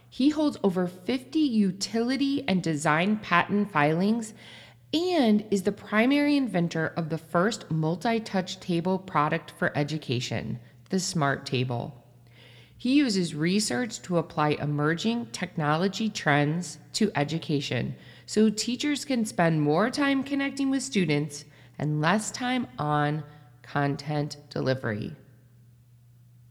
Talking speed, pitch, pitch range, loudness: 115 wpm, 170 Hz, 145-220 Hz, -27 LUFS